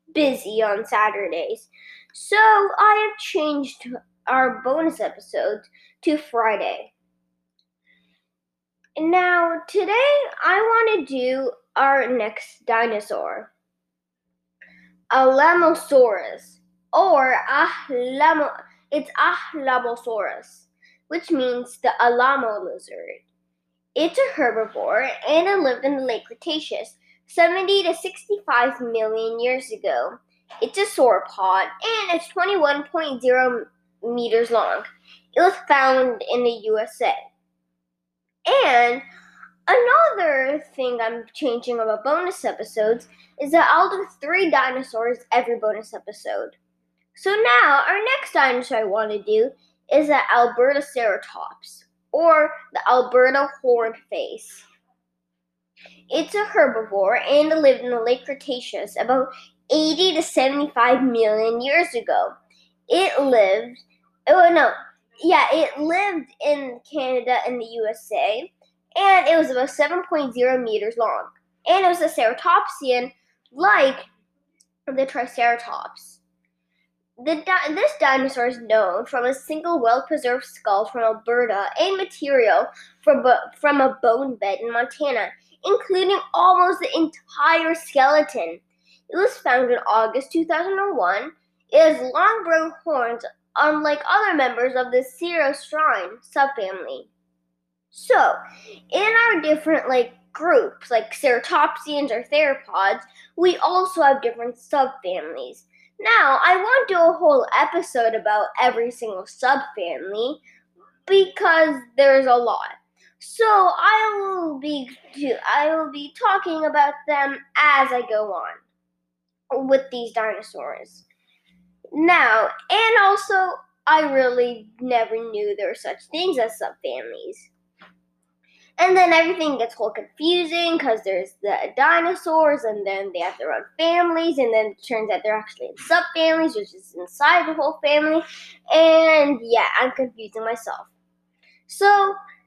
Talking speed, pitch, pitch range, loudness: 120 wpm, 270 Hz, 225-330 Hz, -20 LUFS